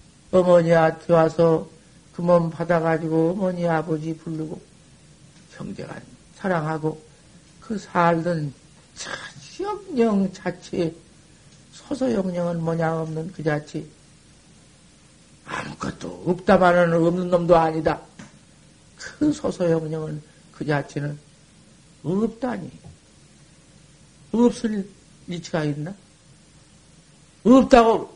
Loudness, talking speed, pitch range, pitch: -22 LUFS, 190 characters per minute, 160-185 Hz, 170 Hz